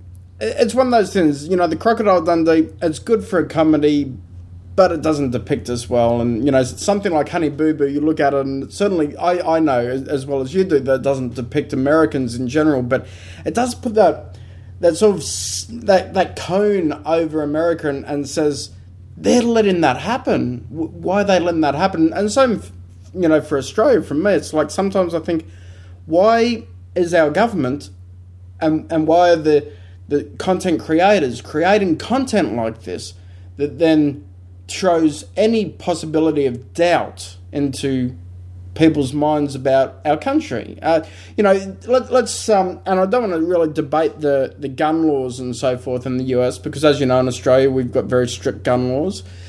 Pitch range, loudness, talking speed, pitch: 120-170 Hz, -17 LUFS, 185 wpm, 145 Hz